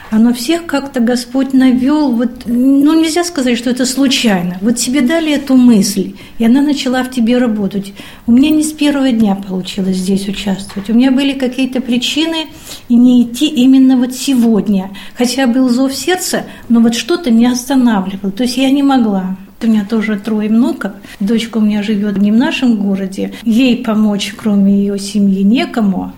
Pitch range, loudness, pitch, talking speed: 205-265 Hz, -12 LUFS, 240 Hz, 180 wpm